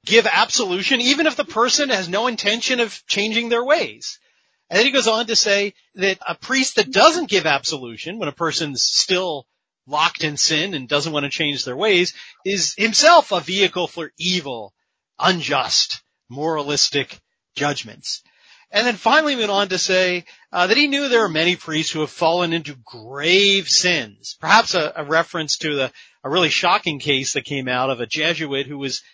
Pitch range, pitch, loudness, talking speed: 150-225 Hz, 180 Hz, -18 LUFS, 185 wpm